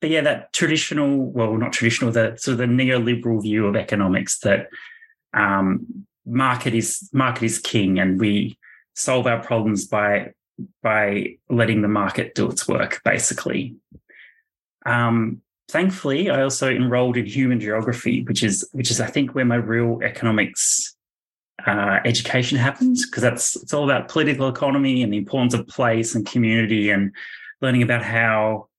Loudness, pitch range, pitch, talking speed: -20 LUFS, 110-135 Hz, 120 Hz, 150 wpm